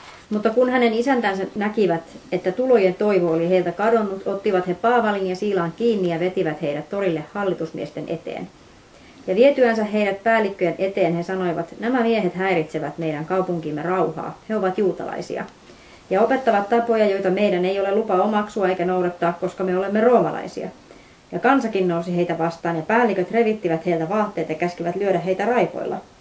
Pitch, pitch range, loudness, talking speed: 190 Hz, 175-215 Hz, -21 LUFS, 160 wpm